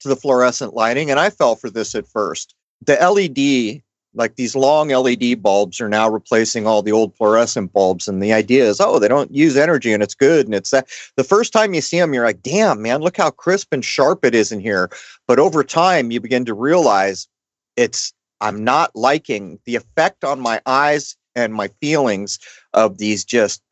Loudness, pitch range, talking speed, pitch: -16 LUFS, 105-135 Hz, 205 wpm, 120 Hz